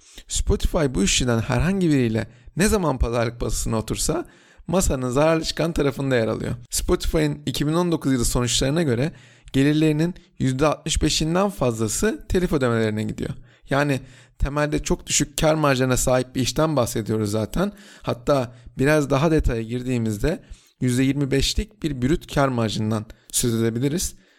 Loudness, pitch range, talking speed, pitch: -22 LUFS, 120-155 Hz, 125 wpm, 135 Hz